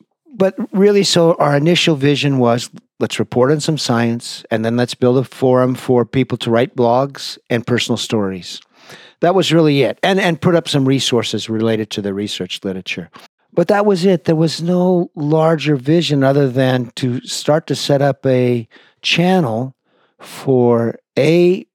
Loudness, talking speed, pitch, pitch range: -15 LUFS, 170 wpm, 140 Hz, 120-170 Hz